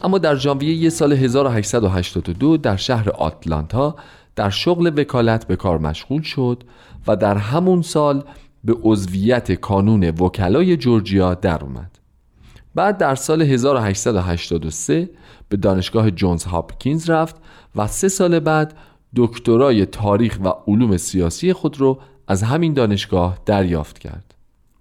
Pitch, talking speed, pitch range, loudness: 115 Hz, 125 wpm, 95-145 Hz, -18 LUFS